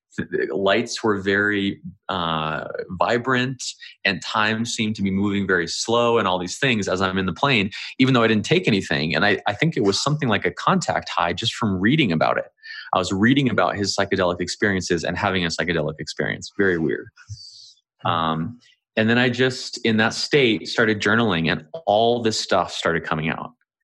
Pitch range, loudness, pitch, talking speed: 90-115 Hz, -21 LUFS, 100 Hz, 190 wpm